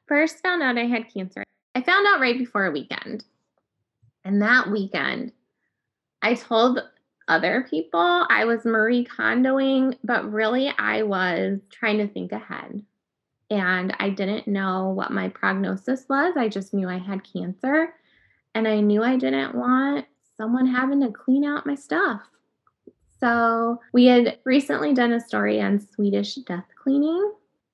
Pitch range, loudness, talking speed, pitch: 195-260 Hz, -22 LUFS, 150 wpm, 230 Hz